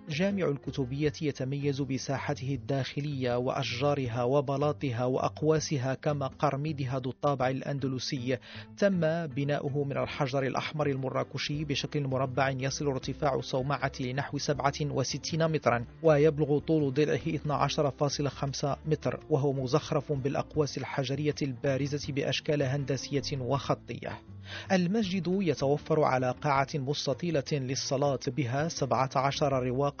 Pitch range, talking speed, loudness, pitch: 135-150 Hz, 100 wpm, -30 LUFS, 140 Hz